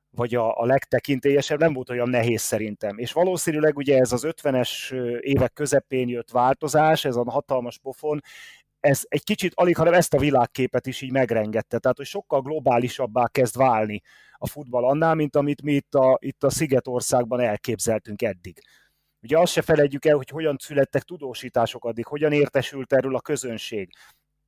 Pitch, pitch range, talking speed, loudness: 135 Hz, 125-150 Hz, 165 wpm, -23 LUFS